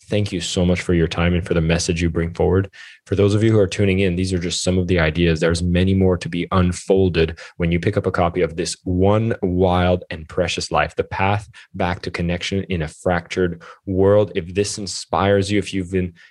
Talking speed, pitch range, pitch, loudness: 235 wpm, 85-100 Hz, 90 Hz, -19 LUFS